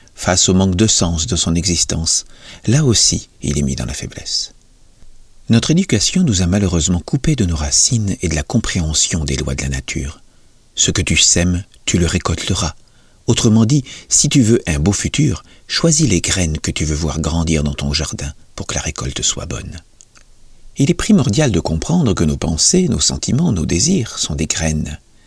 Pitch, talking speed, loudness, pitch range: 85 Hz, 195 wpm, -15 LUFS, 80-110 Hz